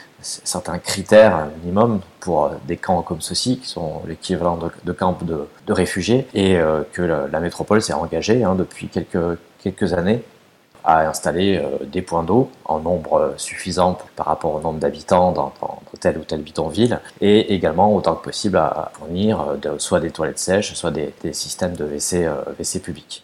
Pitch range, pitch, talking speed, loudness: 80-95 Hz, 90 Hz, 170 wpm, -20 LUFS